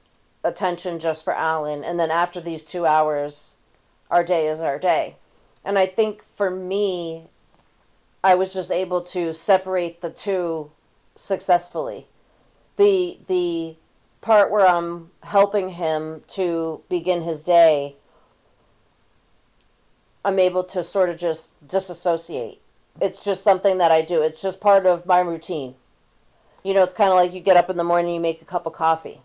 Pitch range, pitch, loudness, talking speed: 165-190 Hz, 175 Hz, -21 LUFS, 160 wpm